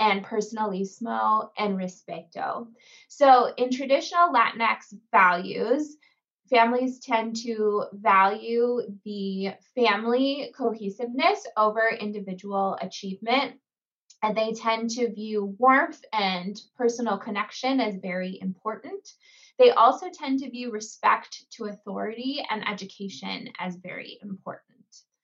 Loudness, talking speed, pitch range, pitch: -25 LUFS, 105 wpm, 200-255 Hz, 225 Hz